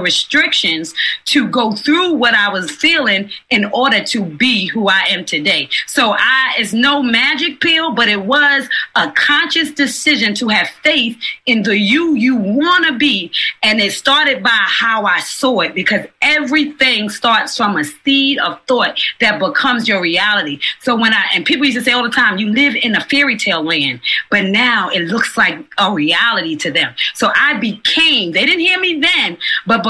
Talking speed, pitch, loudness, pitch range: 190 wpm, 245 Hz, -12 LUFS, 210-290 Hz